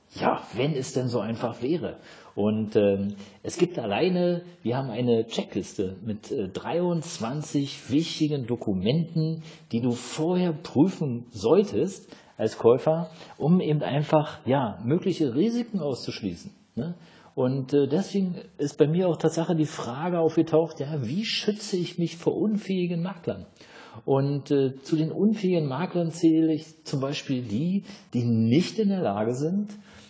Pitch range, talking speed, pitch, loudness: 130-175 Hz, 145 wpm, 155 Hz, -26 LUFS